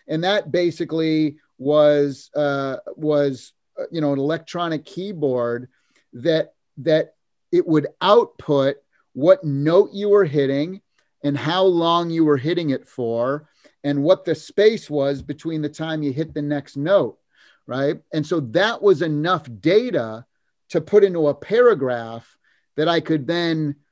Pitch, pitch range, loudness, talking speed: 155 Hz, 140-170 Hz, -20 LUFS, 145 wpm